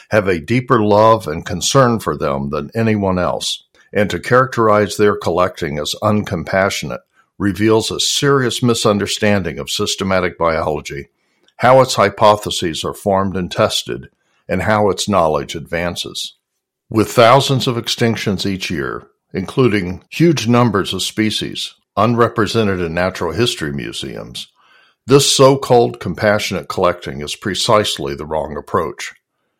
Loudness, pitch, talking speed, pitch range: -16 LUFS, 105 Hz, 130 wpm, 90-115 Hz